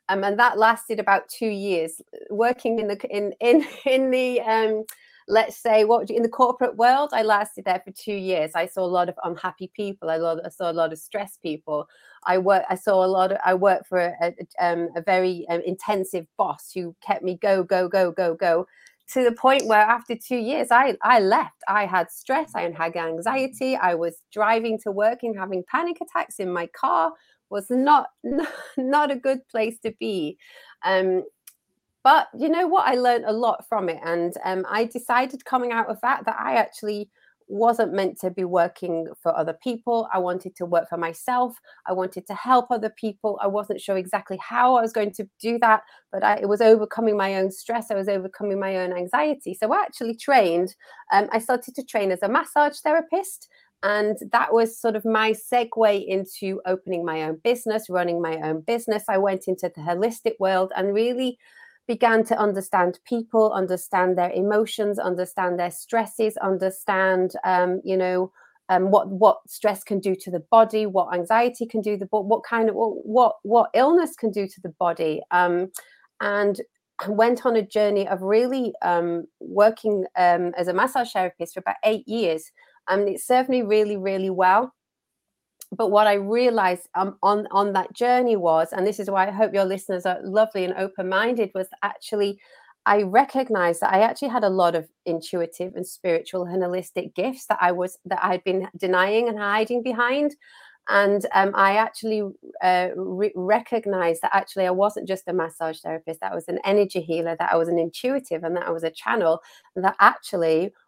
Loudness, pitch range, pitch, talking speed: -23 LUFS, 185-230 Hz, 200 Hz, 195 wpm